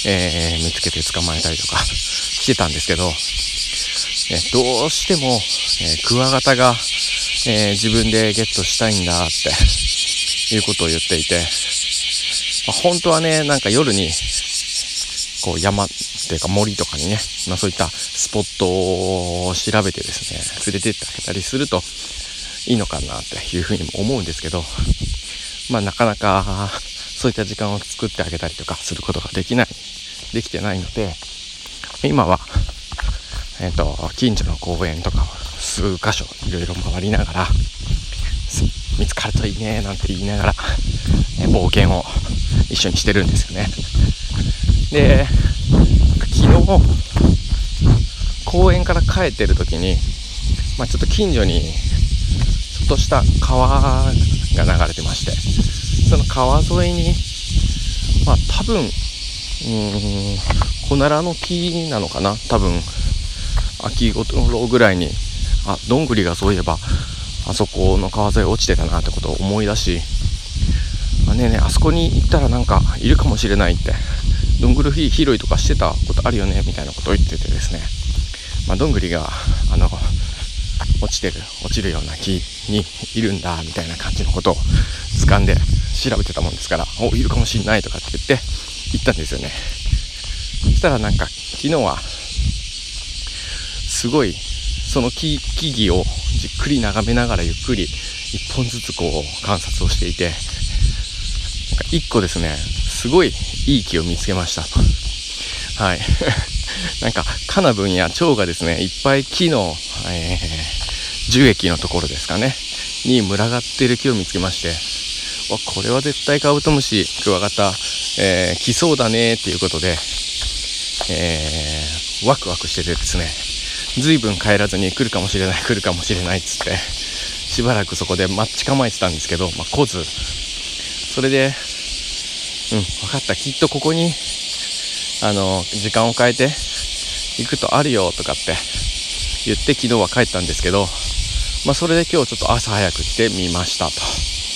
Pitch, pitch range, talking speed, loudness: 90 Hz, 80-105 Hz, 295 characters per minute, -18 LUFS